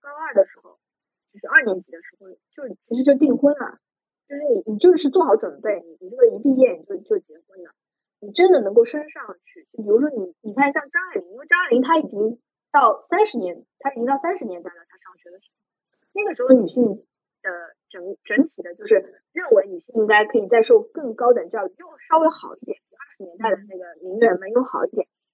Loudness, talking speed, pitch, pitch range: -19 LUFS, 325 characters per minute, 275 Hz, 210-345 Hz